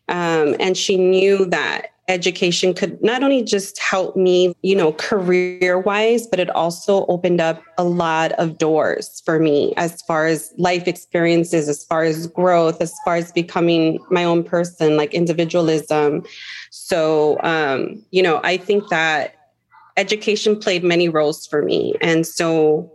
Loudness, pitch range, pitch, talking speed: -18 LUFS, 160-185 Hz, 175 Hz, 155 wpm